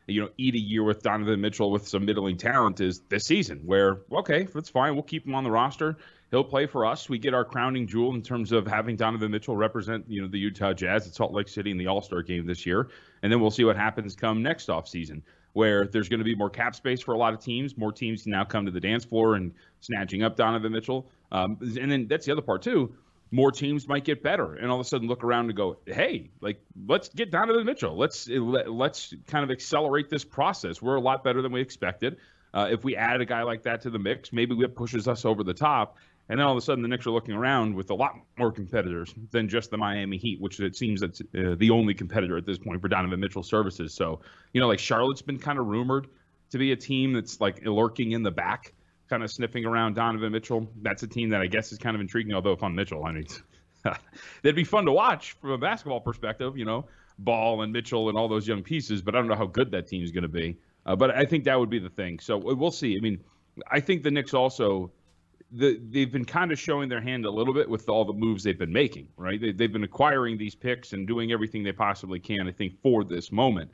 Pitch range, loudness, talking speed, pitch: 100-125 Hz, -27 LUFS, 255 wpm, 115 Hz